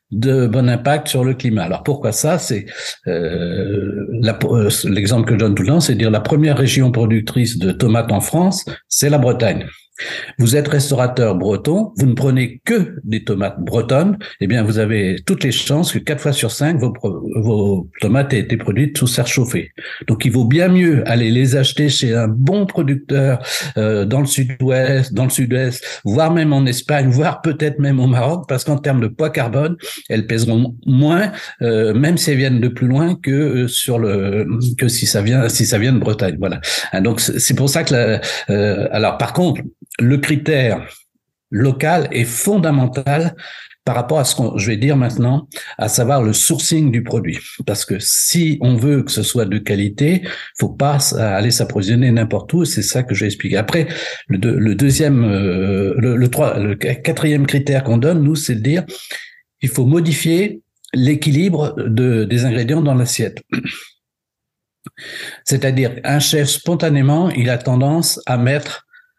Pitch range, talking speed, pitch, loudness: 115-145 Hz, 185 wpm, 130 Hz, -16 LUFS